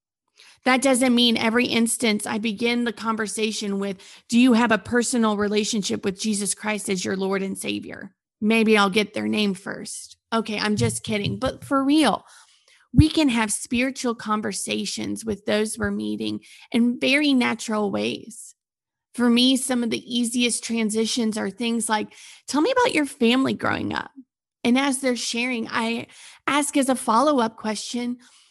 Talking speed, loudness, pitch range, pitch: 165 wpm, -22 LUFS, 210-250 Hz, 225 Hz